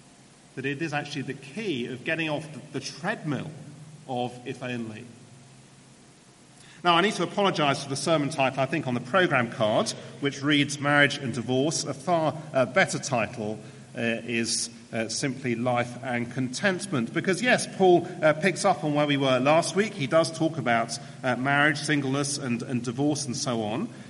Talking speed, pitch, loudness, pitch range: 175 wpm, 140 Hz, -26 LUFS, 125-155 Hz